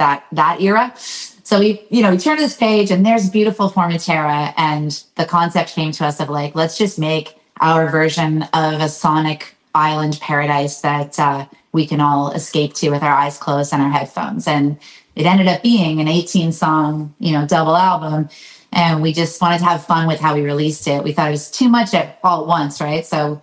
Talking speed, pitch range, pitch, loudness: 215 wpm, 150-180 Hz, 160 Hz, -16 LUFS